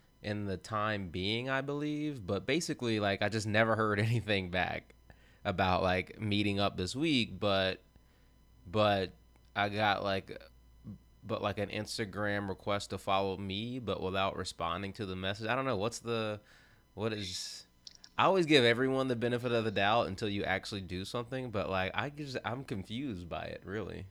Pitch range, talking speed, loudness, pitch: 95-115 Hz, 175 wpm, -33 LUFS, 100 Hz